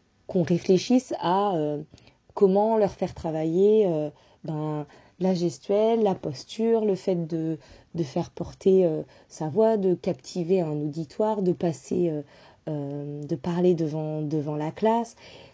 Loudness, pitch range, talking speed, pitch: -26 LUFS, 155-200 Hz, 145 wpm, 175 Hz